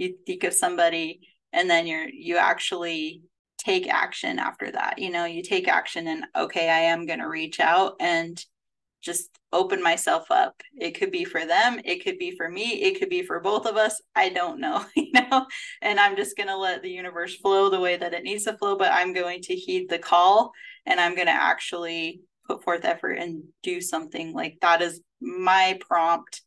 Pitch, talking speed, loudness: 190 Hz, 210 wpm, -24 LUFS